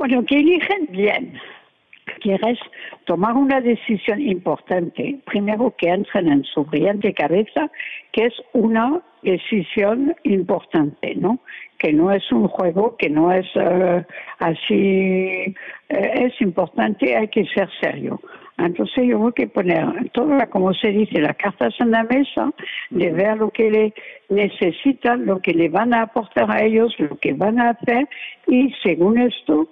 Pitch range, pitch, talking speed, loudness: 185-250 Hz, 215 Hz, 150 wpm, -19 LUFS